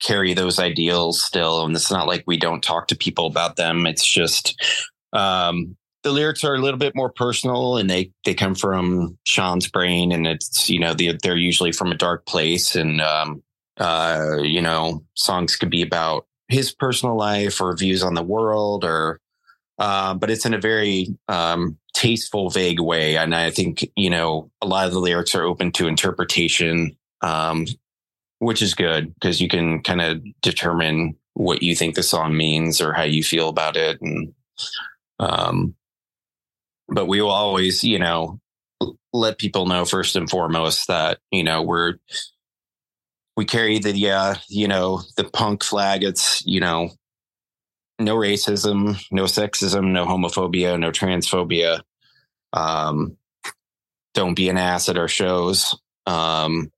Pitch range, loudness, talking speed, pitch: 85-100 Hz, -20 LUFS, 165 wpm, 90 Hz